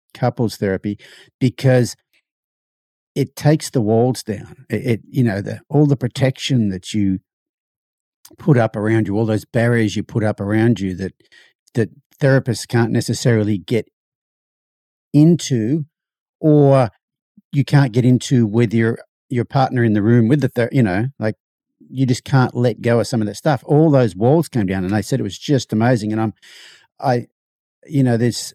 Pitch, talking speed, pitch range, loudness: 120 Hz, 175 wpm, 110-135 Hz, -18 LUFS